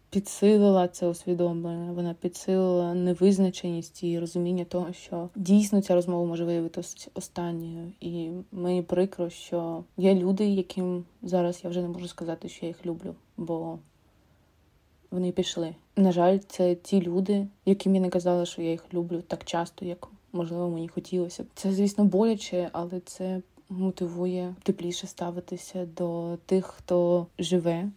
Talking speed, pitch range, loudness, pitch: 145 wpm, 170-185 Hz, -28 LUFS, 180 Hz